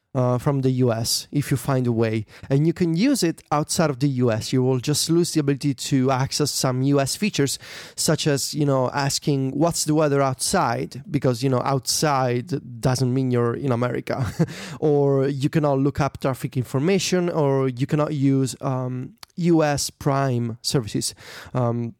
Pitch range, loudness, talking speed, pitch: 130-150 Hz, -22 LUFS, 170 wpm, 140 Hz